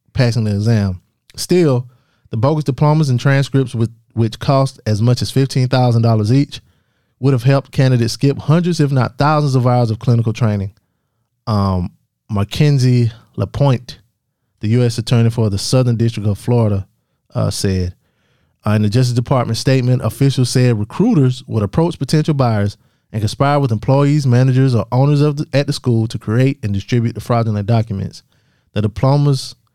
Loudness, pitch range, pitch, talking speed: -16 LUFS, 110-135 Hz, 120 Hz, 155 wpm